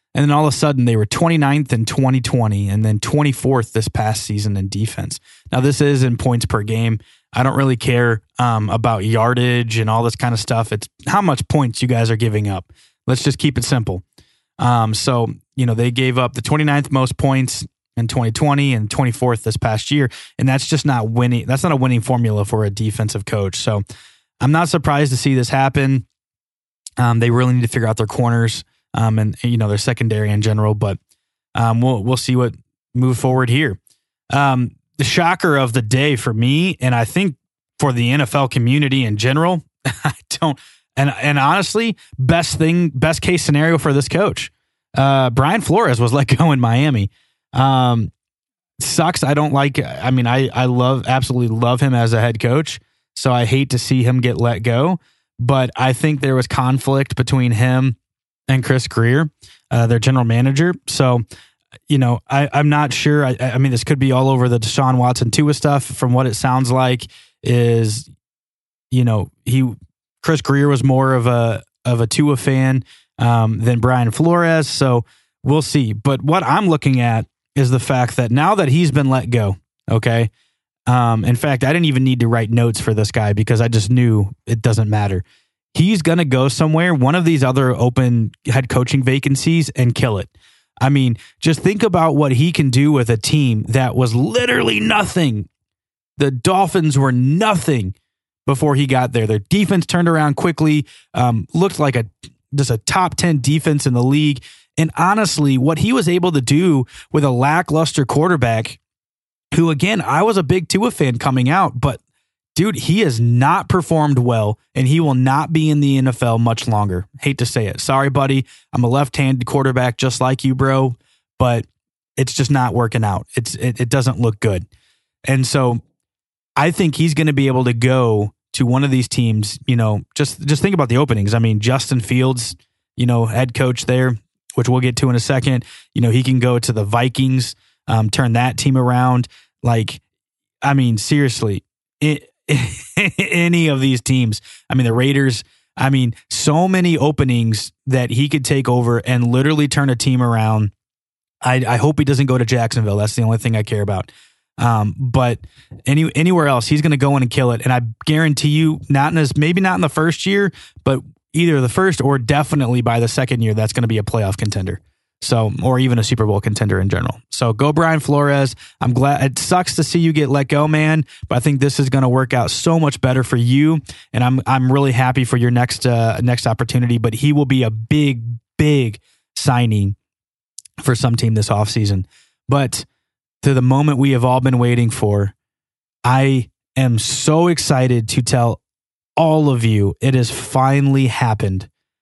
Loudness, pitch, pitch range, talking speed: -16 LUFS, 130 Hz, 115-145 Hz, 195 wpm